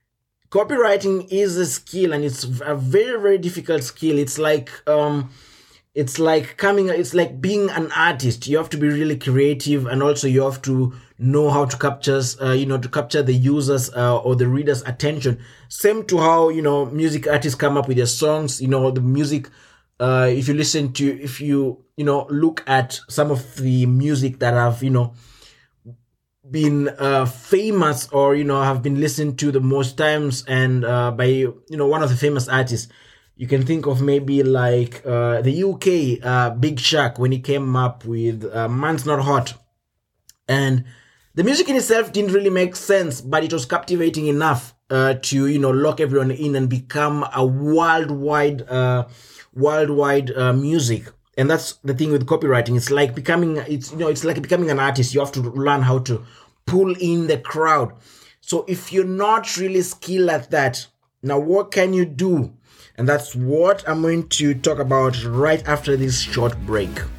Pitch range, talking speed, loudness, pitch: 130-155 Hz, 190 wpm, -19 LUFS, 140 Hz